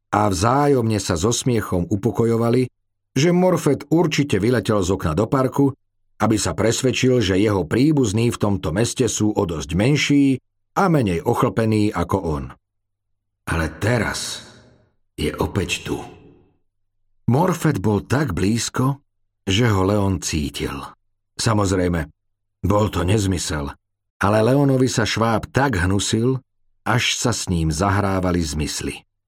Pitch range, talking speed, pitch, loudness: 100-125 Hz, 125 wpm, 105 Hz, -20 LUFS